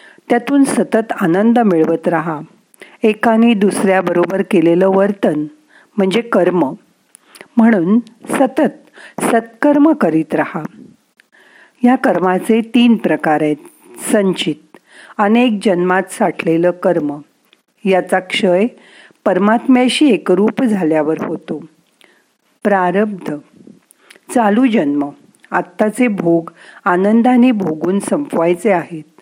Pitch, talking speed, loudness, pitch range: 205 Hz, 85 wpm, -14 LUFS, 175-240 Hz